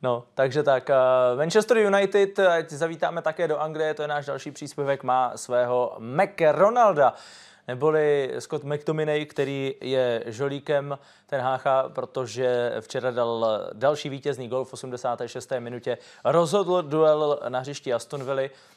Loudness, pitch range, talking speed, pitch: -24 LUFS, 125-155 Hz, 130 wpm, 140 Hz